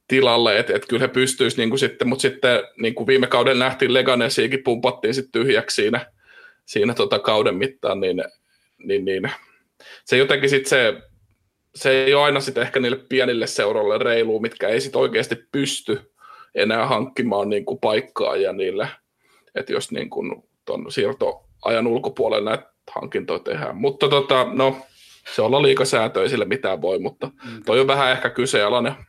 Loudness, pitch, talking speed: -20 LUFS, 400 Hz, 150 wpm